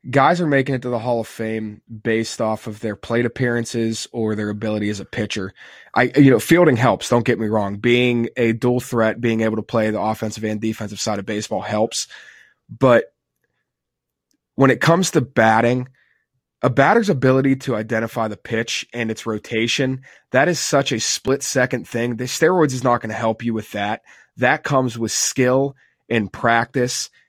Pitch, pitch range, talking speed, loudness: 115 Hz, 110-130 Hz, 185 wpm, -19 LUFS